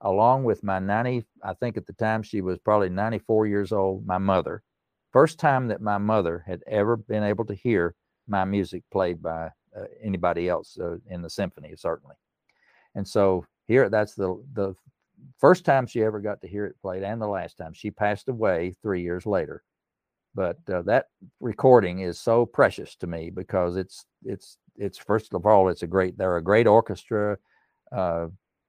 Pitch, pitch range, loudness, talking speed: 100 Hz, 90-110 Hz, -25 LUFS, 185 wpm